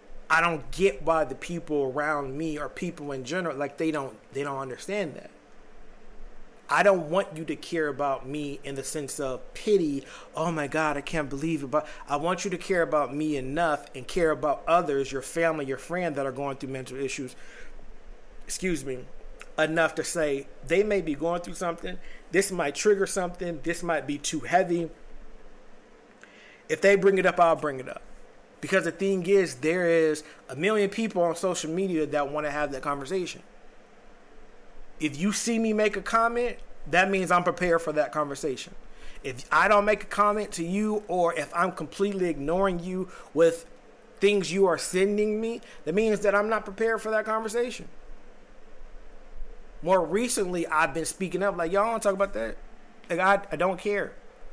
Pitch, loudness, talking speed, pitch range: 170 Hz, -27 LUFS, 185 wpm, 150-200 Hz